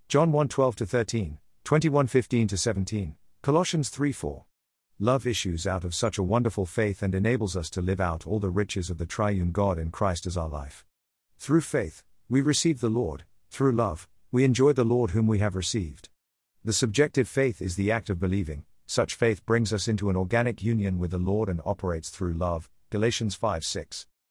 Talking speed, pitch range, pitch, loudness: 180 wpm, 95-120 Hz, 105 Hz, -27 LUFS